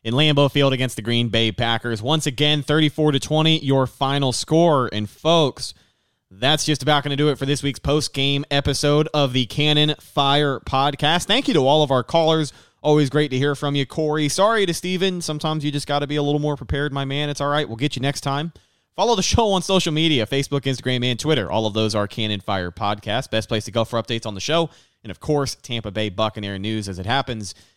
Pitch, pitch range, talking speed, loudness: 140 Hz, 120-150 Hz, 230 wpm, -20 LUFS